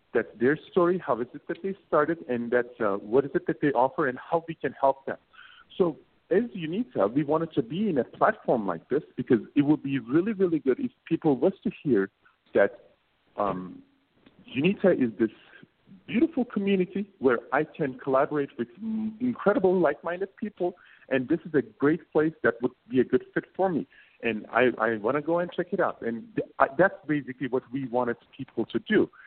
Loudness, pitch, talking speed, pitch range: -27 LUFS, 155 Hz, 200 wpm, 130-185 Hz